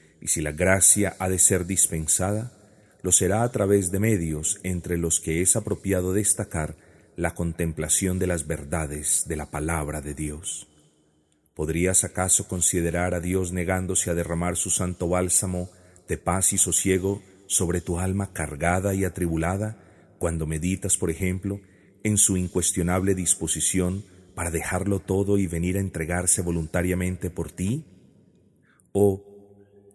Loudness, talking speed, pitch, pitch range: -23 LUFS, 140 wpm, 90 Hz, 85-95 Hz